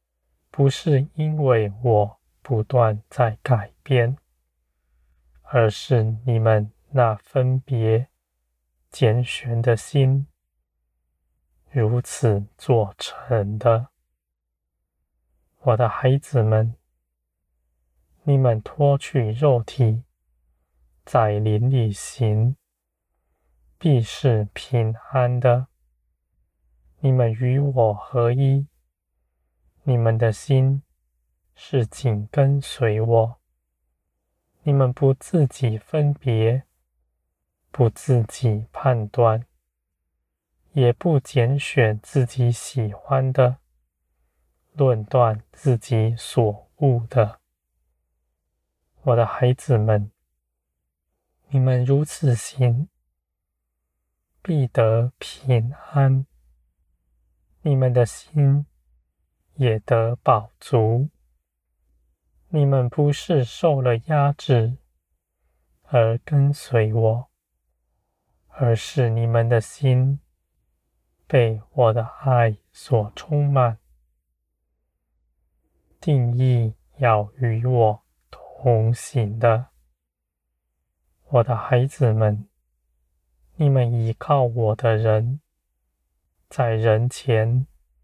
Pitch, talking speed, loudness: 110 Hz, 110 characters per minute, -21 LUFS